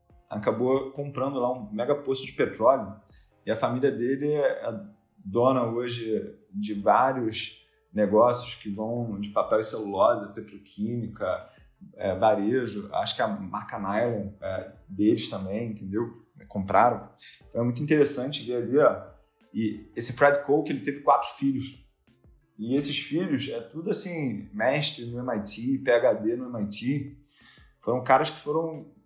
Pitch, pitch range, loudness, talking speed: 130 Hz, 115-145 Hz, -27 LUFS, 135 wpm